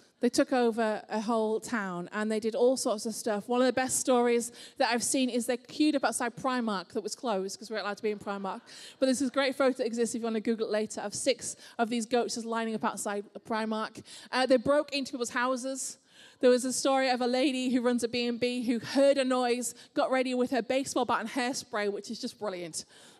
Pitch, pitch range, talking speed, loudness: 240 Hz, 220-255 Hz, 250 wpm, -30 LUFS